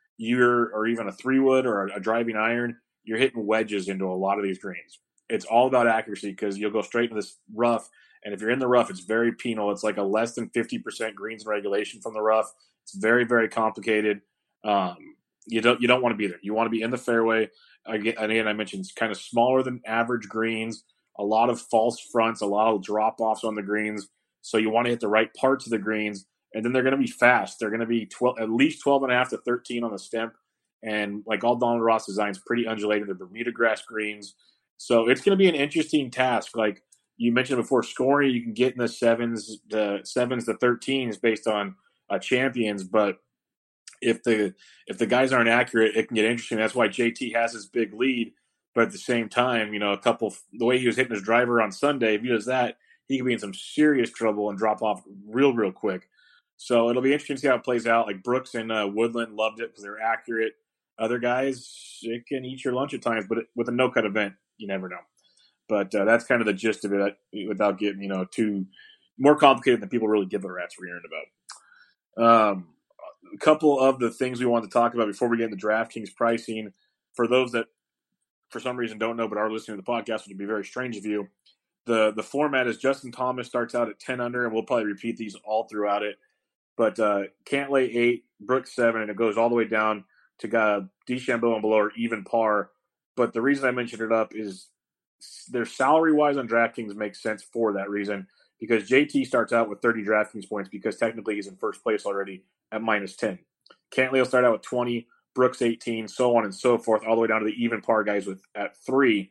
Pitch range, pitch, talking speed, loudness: 105-120 Hz, 115 Hz, 235 wpm, -25 LUFS